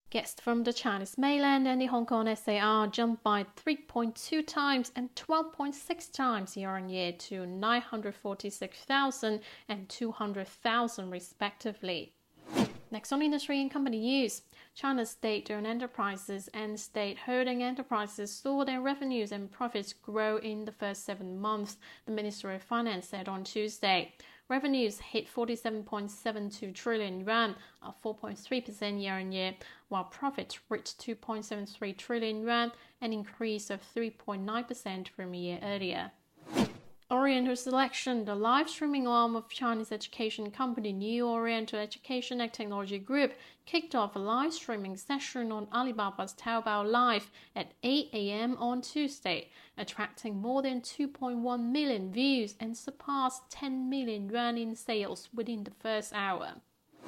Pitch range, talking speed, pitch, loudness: 205-255 Hz, 135 wpm, 225 Hz, -34 LUFS